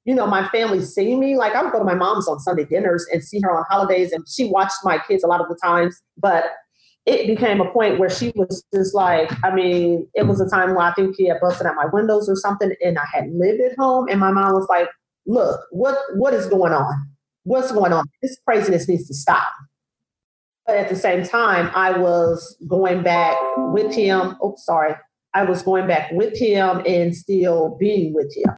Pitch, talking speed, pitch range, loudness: 185 Hz, 225 wpm, 170-200 Hz, -19 LUFS